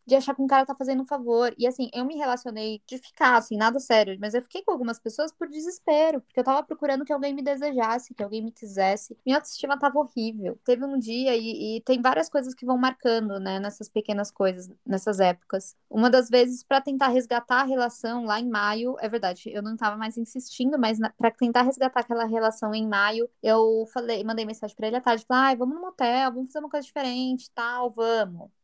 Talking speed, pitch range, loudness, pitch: 225 wpm, 220-265 Hz, -25 LUFS, 245 Hz